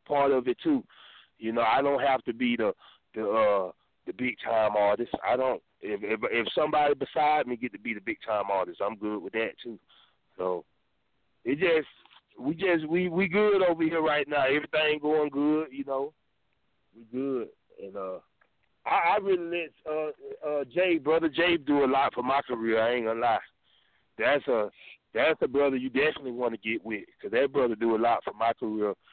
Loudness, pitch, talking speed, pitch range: -28 LUFS, 140 Hz, 200 wpm, 120-165 Hz